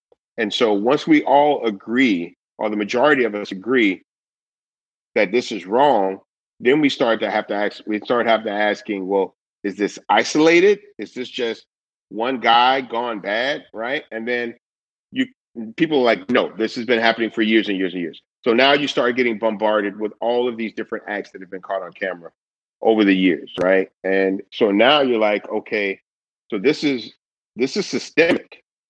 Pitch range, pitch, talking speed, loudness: 100-120 Hz, 110 Hz, 190 wpm, -19 LUFS